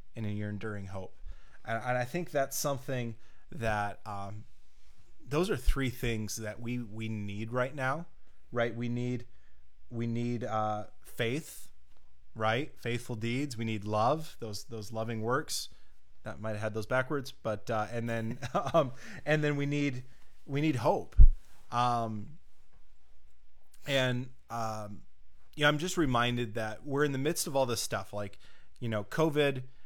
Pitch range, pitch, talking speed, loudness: 105-130 Hz, 115 Hz, 160 wpm, -33 LUFS